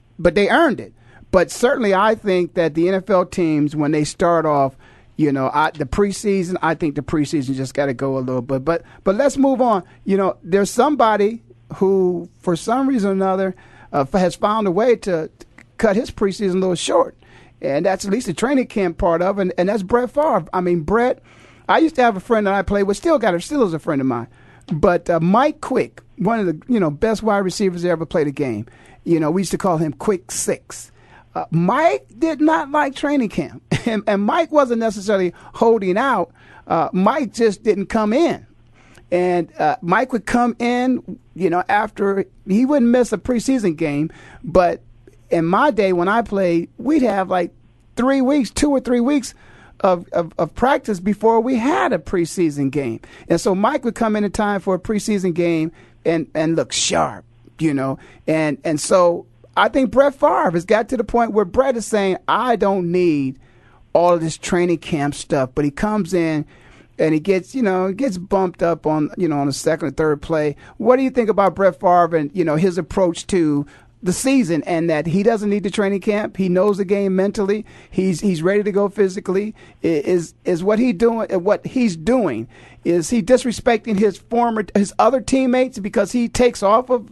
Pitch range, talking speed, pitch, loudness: 165-225 Hz, 210 wpm, 190 Hz, -18 LUFS